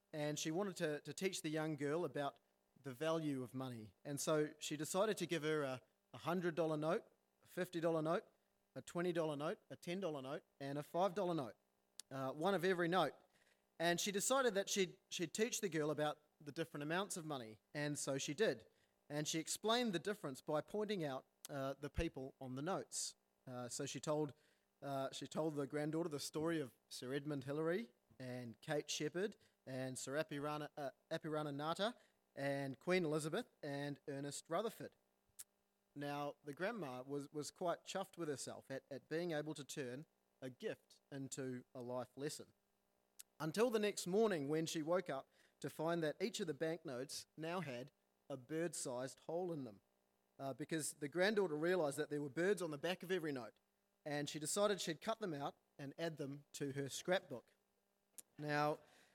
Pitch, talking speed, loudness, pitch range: 150 Hz, 180 wpm, -43 LUFS, 140-170 Hz